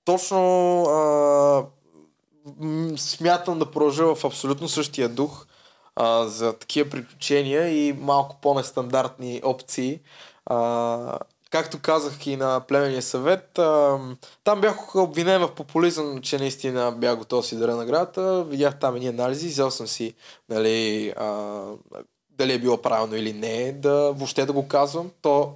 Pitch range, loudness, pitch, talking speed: 125-155 Hz, -23 LUFS, 140 Hz, 145 wpm